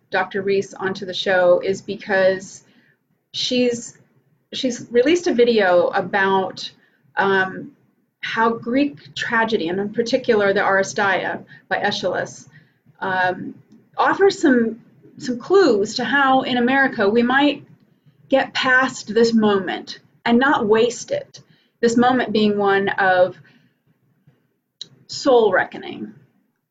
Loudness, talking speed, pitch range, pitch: -19 LUFS, 110 wpm, 195-255 Hz, 225 Hz